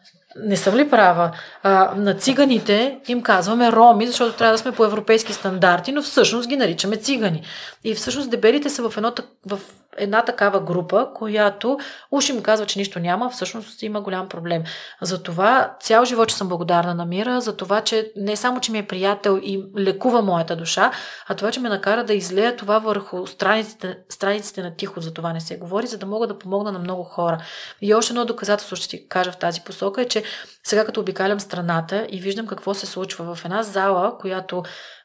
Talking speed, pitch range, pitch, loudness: 195 wpm, 185-225 Hz, 205 Hz, -20 LUFS